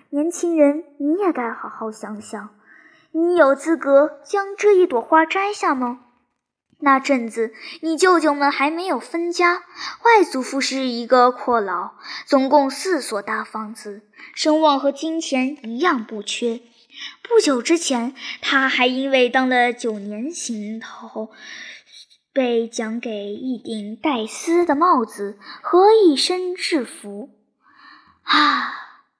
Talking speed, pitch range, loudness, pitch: 180 characters per minute, 230-325 Hz, -19 LUFS, 270 Hz